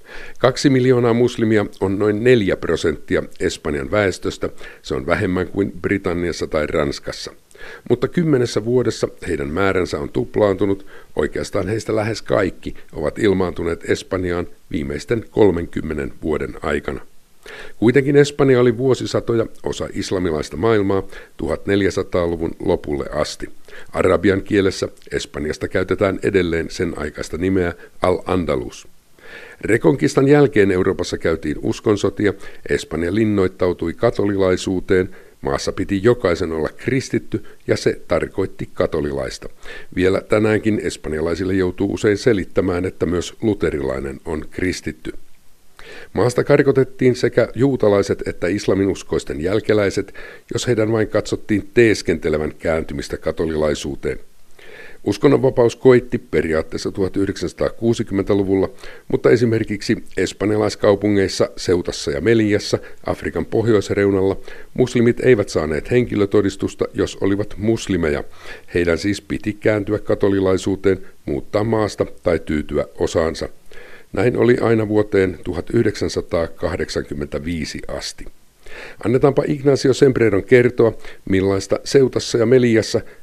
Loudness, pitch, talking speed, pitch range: -19 LUFS, 105 Hz, 100 wpm, 95-120 Hz